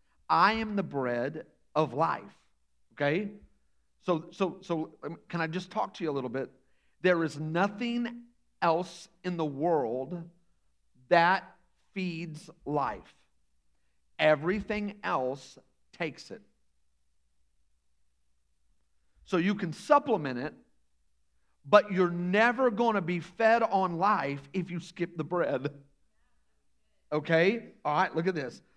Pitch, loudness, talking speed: 160 Hz, -30 LUFS, 120 wpm